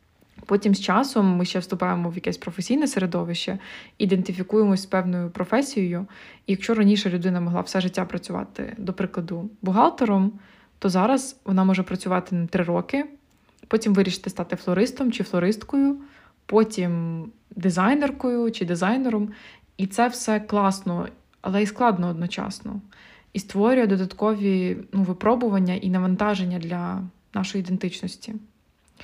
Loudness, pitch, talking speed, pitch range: -24 LUFS, 195 Hz, 125 wpm, 185-220 Hz